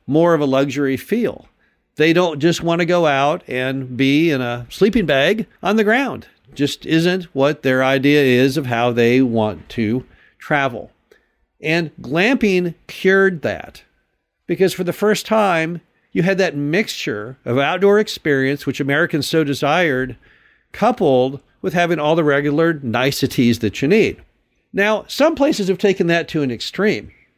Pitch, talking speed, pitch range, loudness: 155 Hz, 160 wpm, 135-185 Hz, -17 LUFS